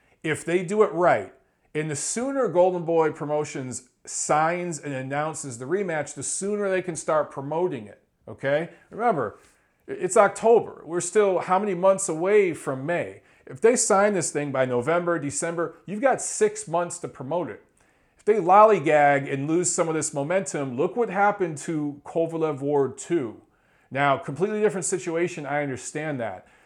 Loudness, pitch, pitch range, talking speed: -24 LUFS, 170 Hz, 145-195 Hz, 165 wpm